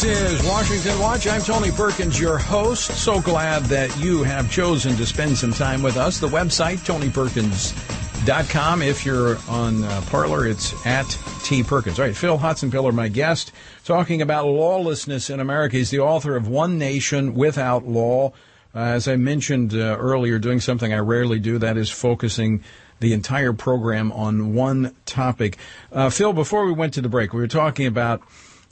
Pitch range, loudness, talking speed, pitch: 115-150 Hz, -21 LUFS, 175 wpm, 130 Hz